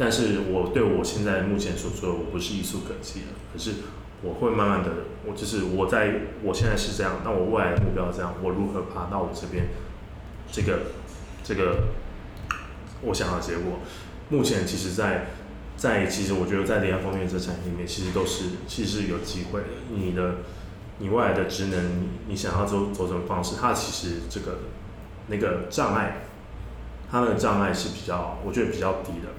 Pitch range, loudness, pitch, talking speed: 90-100 Hz, -27 LUFS, 95 Hz, 285 characters per minute